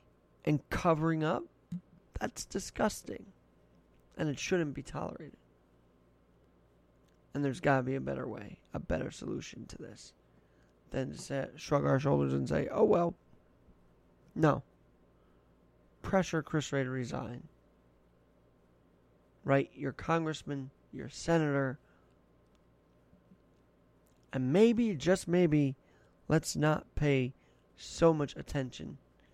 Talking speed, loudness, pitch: 110 wpm, -33 LUFS, 130 Hz